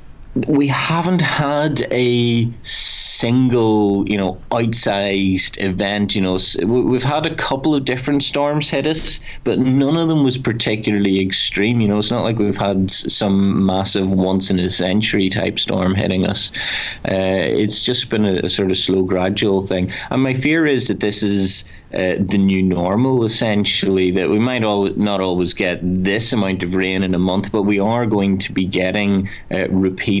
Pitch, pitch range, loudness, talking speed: 100 Hz, 95-120 Hz, -17 LUFS, 175 wpm